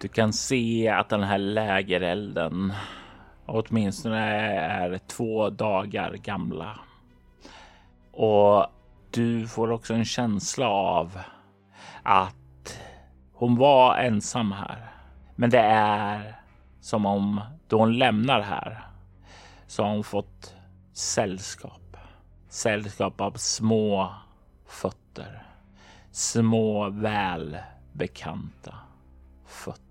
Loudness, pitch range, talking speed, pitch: -25 LUFS, 90-110 Hz, 90 wpm, 100 Hz